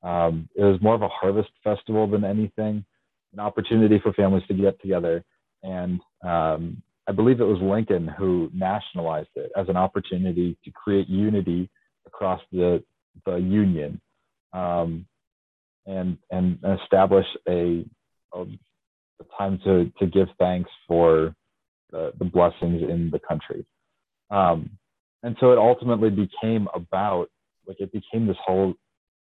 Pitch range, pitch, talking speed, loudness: 90-105 Hz, 95 Hz, 140 wpm, -23 LUFS